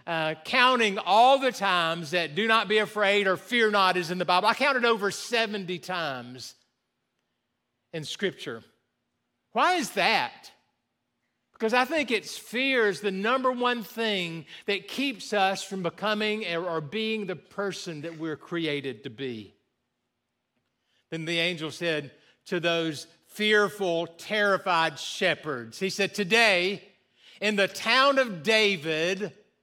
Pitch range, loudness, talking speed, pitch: 165-215 Hz, -26 LUFS, 140 wpm, 190 Hz